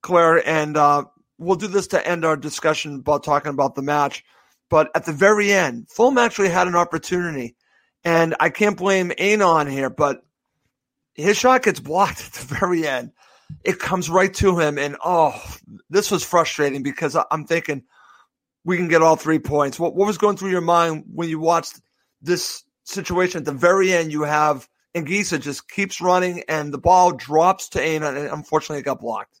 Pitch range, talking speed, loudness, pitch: 150-190 Hz, 190 wpm, -19 LUFS, 165 Hz